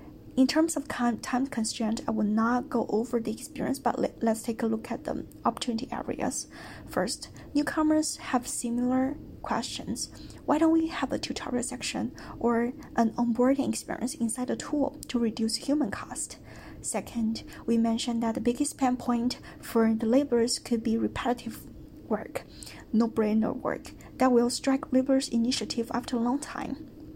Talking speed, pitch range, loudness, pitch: 155 wpm, 230-270 Hz, -29 LUFS, 245 Hz